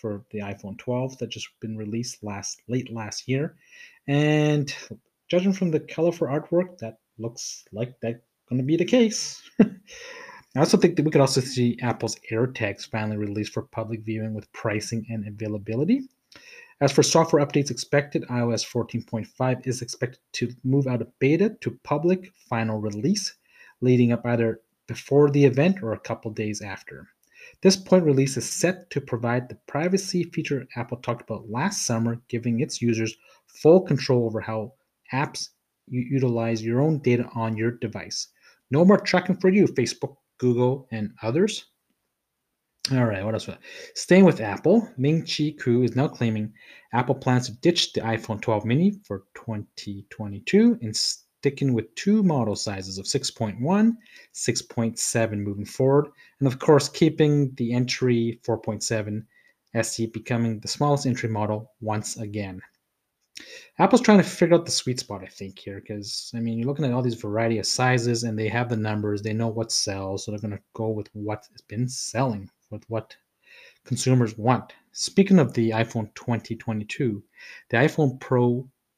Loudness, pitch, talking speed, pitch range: -24 LUFS, 120 Hz, 165 wpm, 110-145 Hz